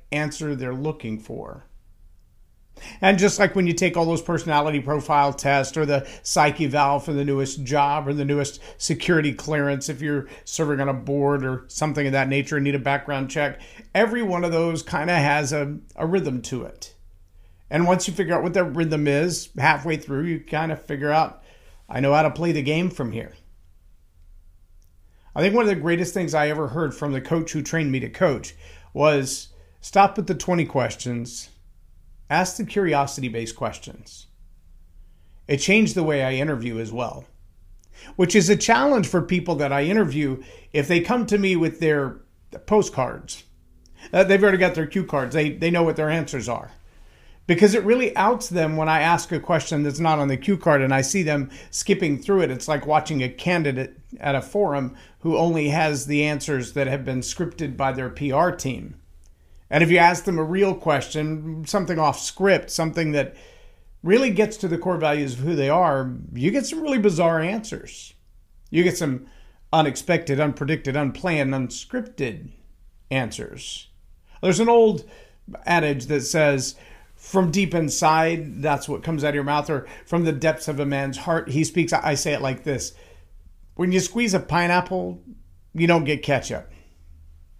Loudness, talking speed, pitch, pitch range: -22 LUFS, 185 wpm, 150 Hz, 130-170 Hz